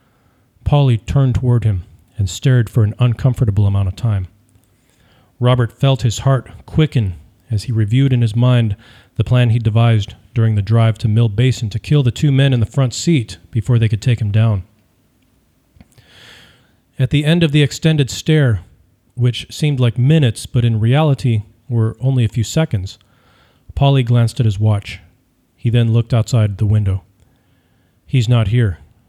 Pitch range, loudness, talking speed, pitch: 105-130 Hz, -16 LUFS, 165 wpm, 115 Hz